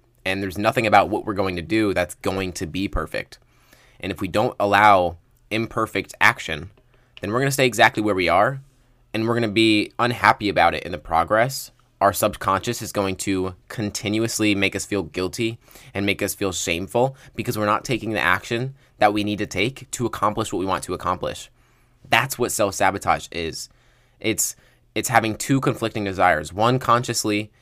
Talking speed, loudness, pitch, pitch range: 185 wpm, -21 LUFS, 110 Hz, 95-120 Hz